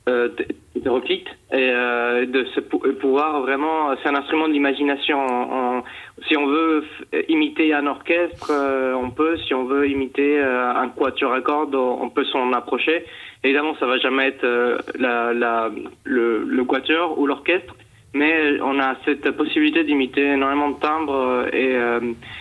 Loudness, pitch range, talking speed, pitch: -20 LUFS, 125-150 Hz, 145 wpm, 135 Hz